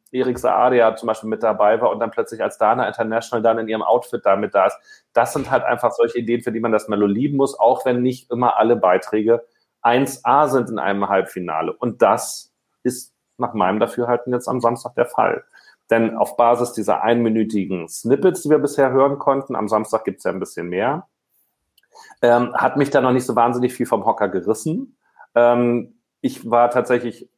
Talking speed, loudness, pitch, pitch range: 195 wpm, -19 LUFS, 120 Hz, 110-125 Hz